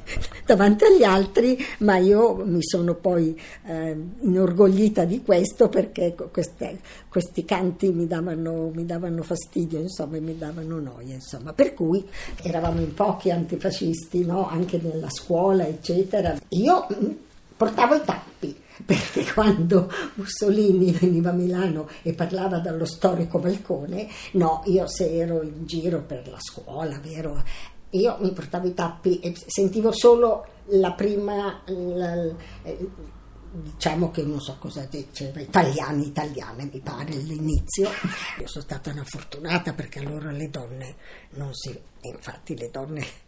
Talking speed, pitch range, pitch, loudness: 140 wpm, 155-190 Hz, 175 Hz, -23 LUFS